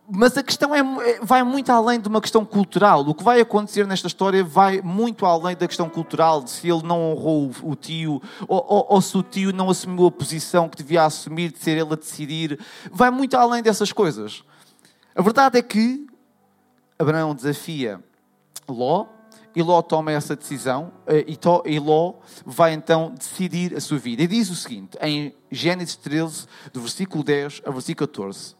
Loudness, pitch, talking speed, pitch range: -21 LUFS, 175 Hz, 180 wpm, 155-205 Hz